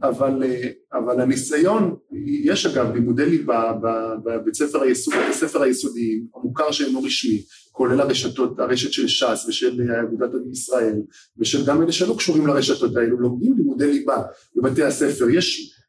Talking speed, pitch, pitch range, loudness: 145 wpm, 135 Hz, 120-185 Hz, -20 LUFS